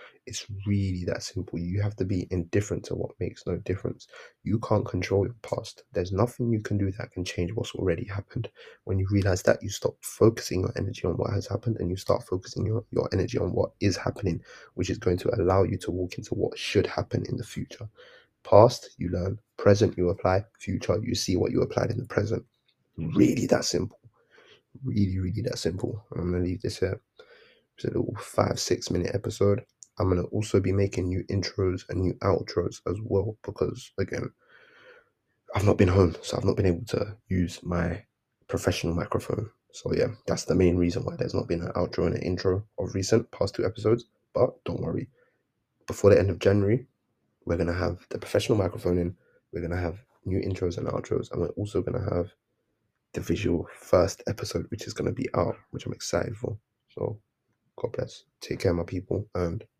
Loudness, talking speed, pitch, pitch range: -28 LUFS, 200 wpm, 100 Hz, 90-115 Hz